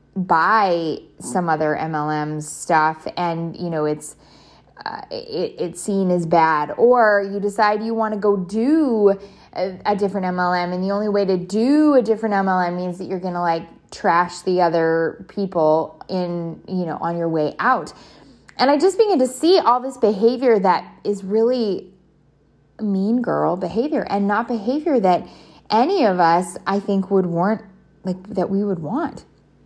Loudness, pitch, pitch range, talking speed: -19 LUFS, 190 Hz, 170-220 Hz, 170 wpm